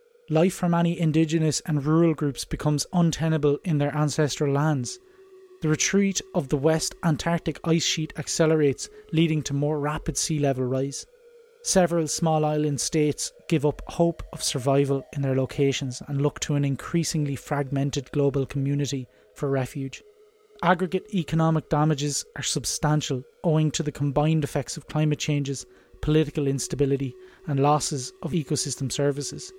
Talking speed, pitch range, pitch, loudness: 145 wpm, 140-165 Hz, 150 Hz, -25 LUFS